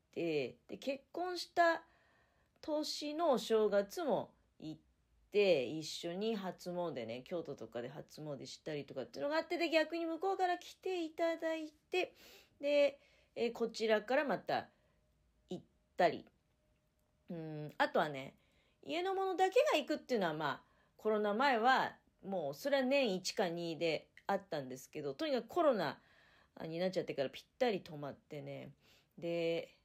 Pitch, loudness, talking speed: 225 Hz, -37 LUFS, 280 characters per minute